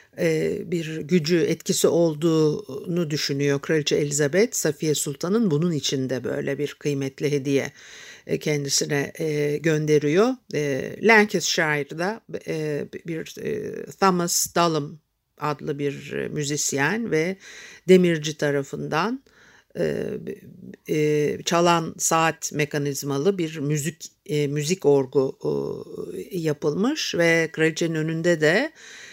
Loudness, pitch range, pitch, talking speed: -23 LUFS, 145-180 Hz, 155 Hz, 80 wpm